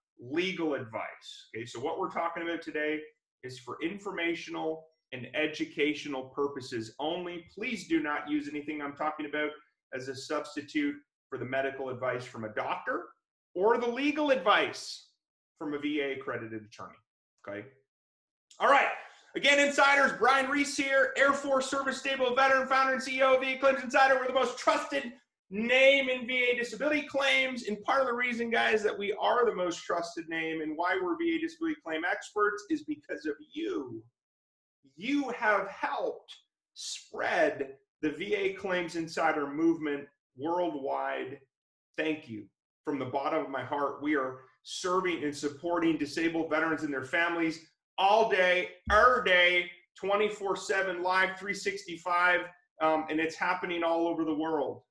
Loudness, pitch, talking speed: -29 LUFS, 170 Hz, 155 wpm